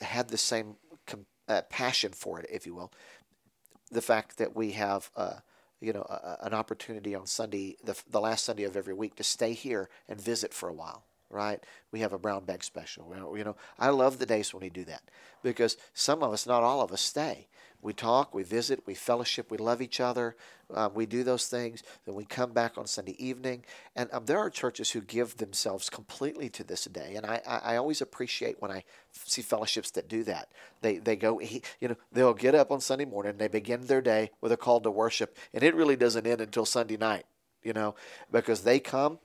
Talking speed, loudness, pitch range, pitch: 220 wpm, -31 LUFS, 105-120 Hz, 115 Hz